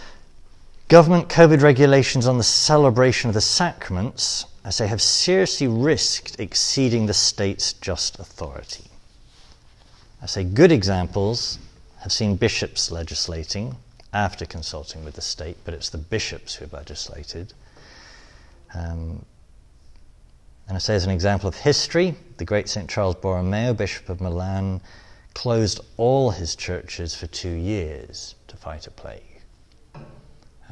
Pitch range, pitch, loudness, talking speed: 85-120 Hz, 100 Hz, -20 LUFS, 130 wpm